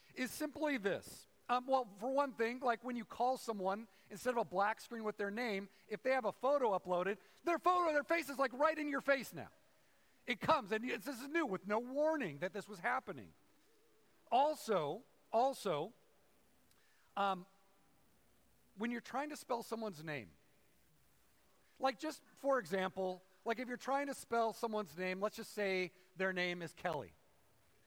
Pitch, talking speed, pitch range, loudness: 230 Hz, 175 wpm, 195-270 Hz, -39 LUFS